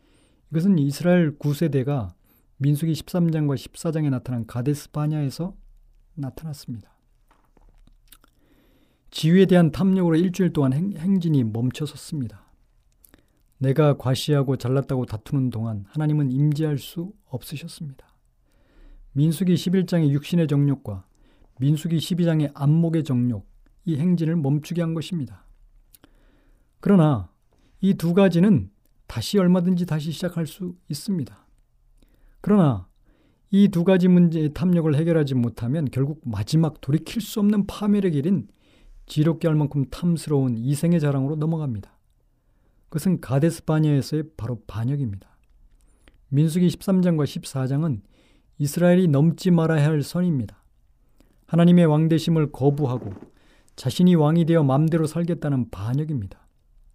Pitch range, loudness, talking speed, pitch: 130-170 Hz, -22 LUFS, 290 characters per minute, 150 Hz